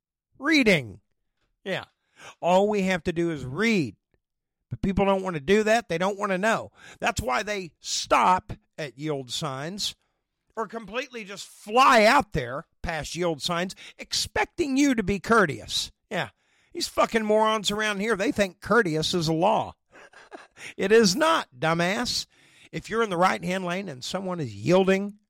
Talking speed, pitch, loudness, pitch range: 165 wpm, 195 Hz, -24 LUFS, 165-220 Hz